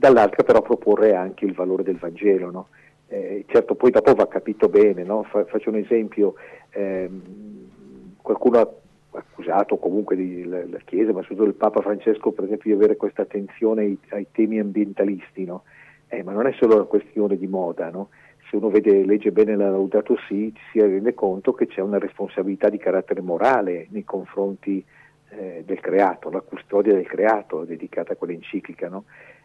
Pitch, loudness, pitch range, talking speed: 100 Hz, -21 LUFS, 95-110 Hz, 175 wpm